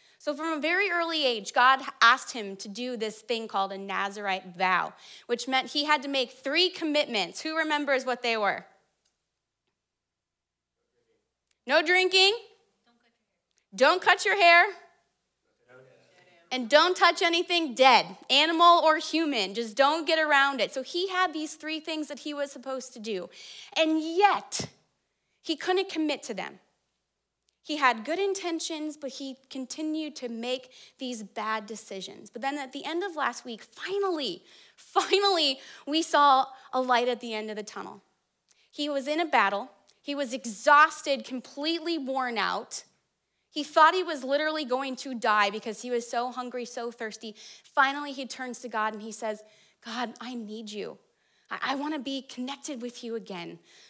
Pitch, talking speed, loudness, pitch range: 275 Hz, 165 wpm, -26 LUFS, 235-315 Hz